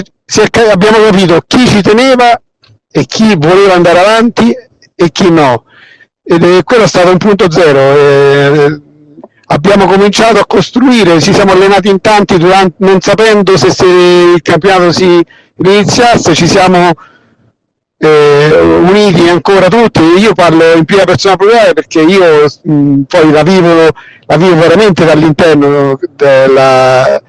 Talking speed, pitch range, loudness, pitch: 140 wpm, 155-200 Hz, -5 LUFS, 180 Hz